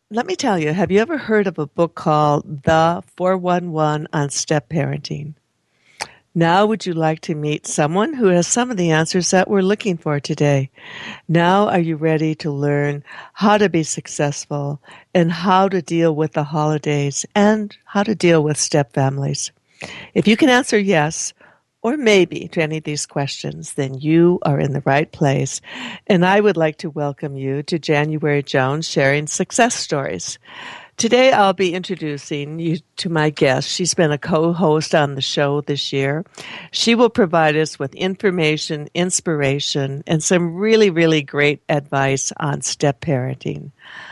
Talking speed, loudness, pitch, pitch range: 170 wpm, -18 LUFS, 160 Hz, 145-185 Hz